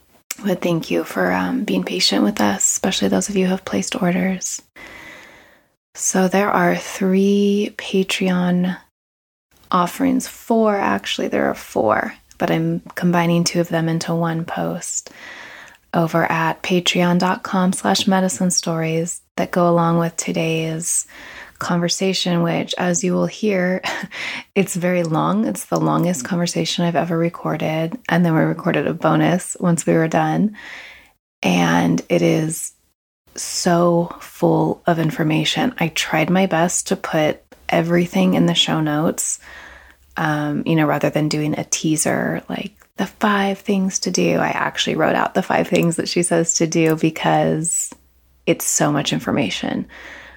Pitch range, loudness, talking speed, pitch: 160-185 Hz, -19 LUFS, 145 wpm, 170 Hz